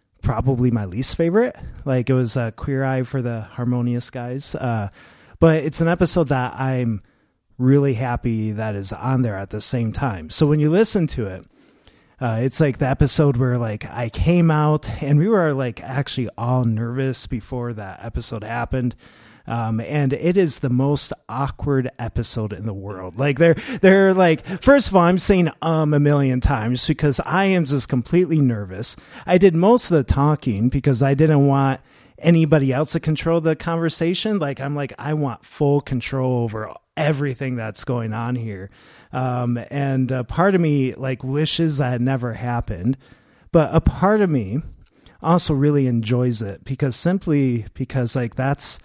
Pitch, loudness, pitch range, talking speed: 135 Hz, -20 LUFS, 120-155 Hz, 175 wpm